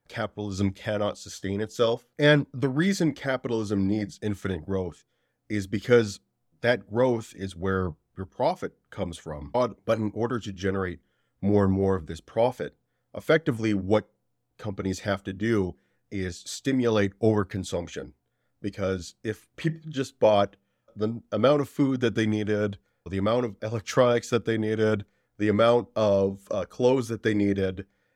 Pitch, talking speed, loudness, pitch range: 105 Hz, 145 wpm, -27 LUFS, 95-115 Hz